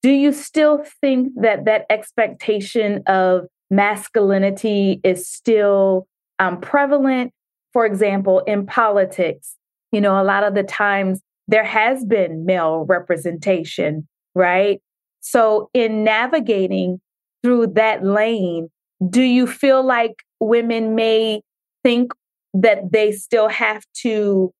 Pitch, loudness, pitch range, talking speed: 215 Hz, -17 LUFS, 190-230 Hz, 115 wpm